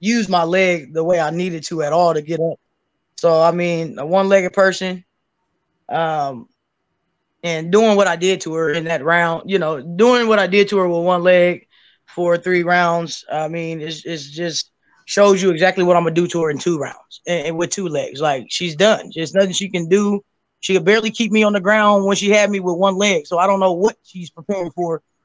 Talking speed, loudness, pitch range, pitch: 235 wpm, -17 LUFS, 165-195 Hz, 180 Hz